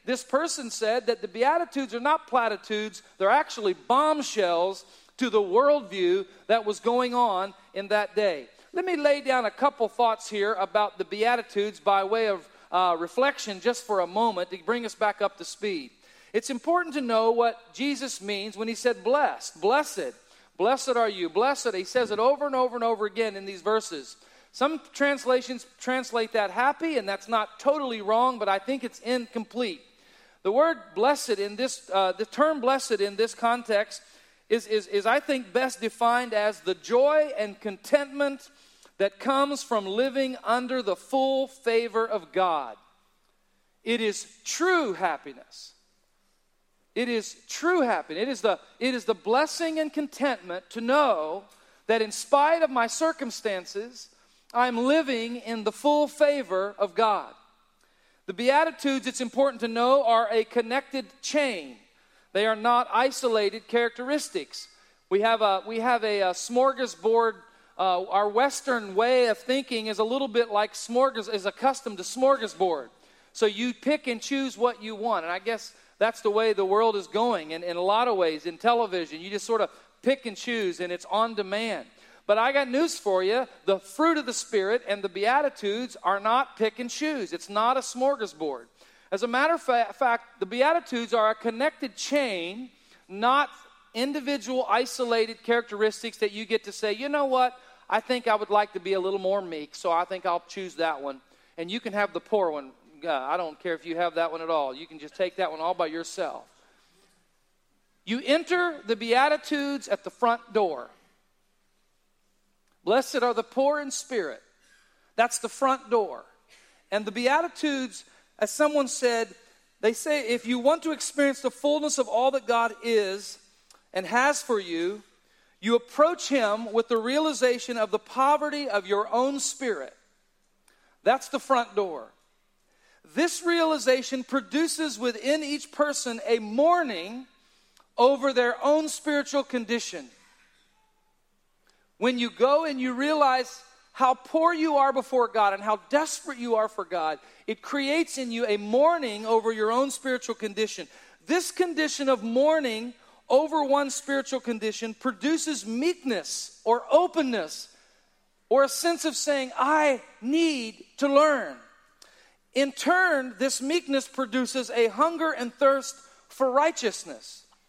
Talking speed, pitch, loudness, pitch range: 165 wpm, 245 Hz, -26 LUFS, 215-280 Hz